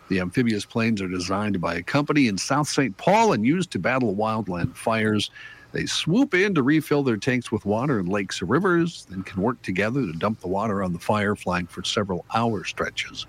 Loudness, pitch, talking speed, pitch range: -23 LUFS, 105 Hz, 210 wpm, 95-125 Hz